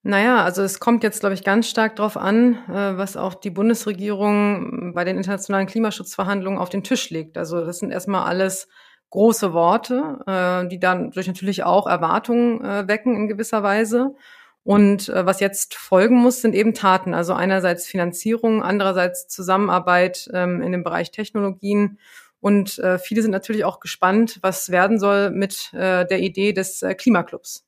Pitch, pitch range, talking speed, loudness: 200 Hz, 185-220 Hz, 155 wpm, -20 LUFS